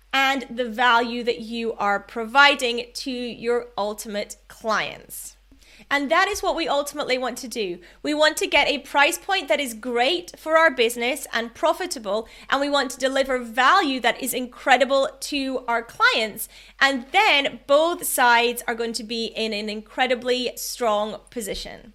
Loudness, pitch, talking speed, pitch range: -22 LUFS, 255 Hz, 165 wpm, 235-285 Hz